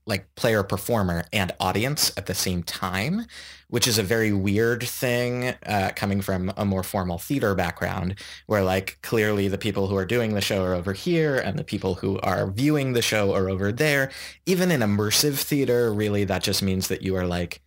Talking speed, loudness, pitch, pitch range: 200 wpm, -24 LUFS, 100 Hz, 95-120 Hz